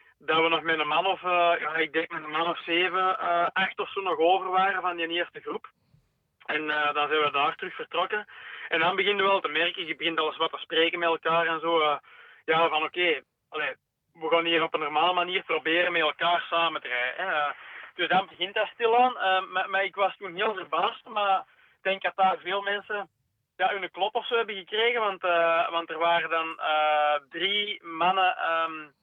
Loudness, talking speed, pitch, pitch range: -26 LUFS, 225 wpm, 170 Hz, 160-190 Hz